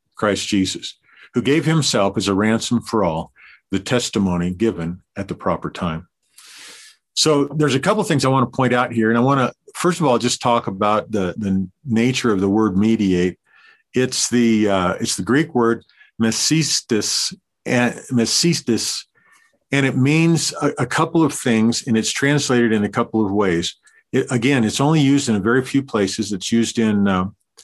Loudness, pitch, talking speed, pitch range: -18 LUFS, 115 Hz, 185 wpm, 105-140 Hz